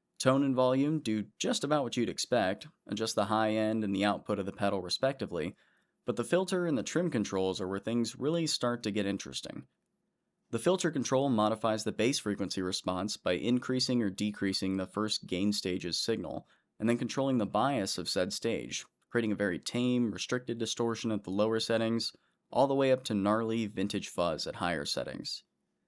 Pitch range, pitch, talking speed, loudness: 100-125 Hz, 110 Hz, 190 wpm, -32 LUFS